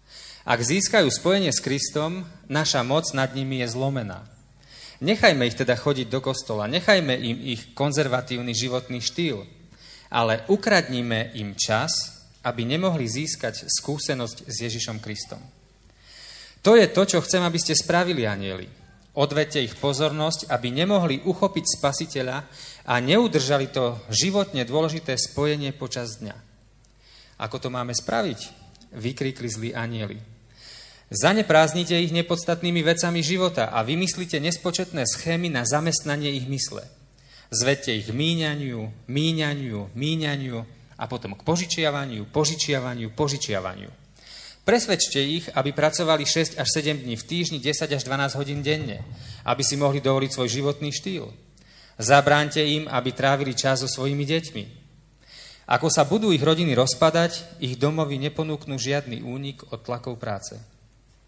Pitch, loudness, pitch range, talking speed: 140 Hz, -23 LUFS, 120-155 Hz, 130 wpm